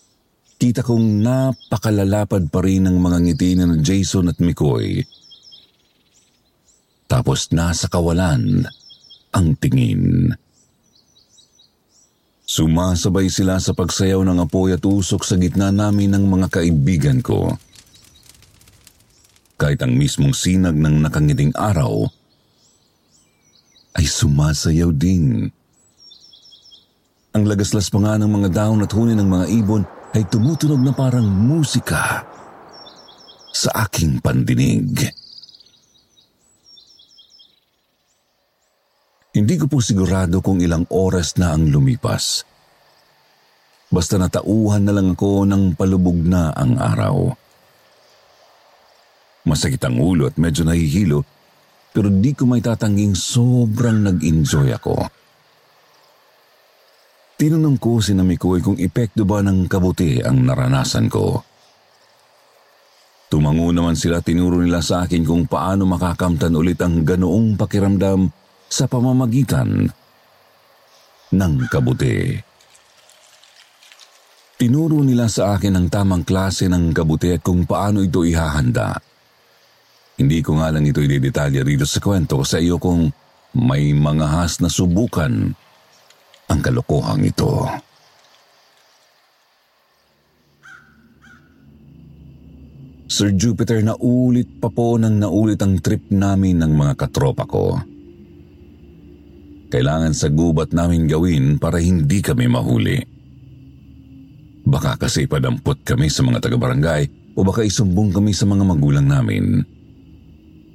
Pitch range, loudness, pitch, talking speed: 85-115 Hz, -17 LUFS, 95 Hz, 105 wpm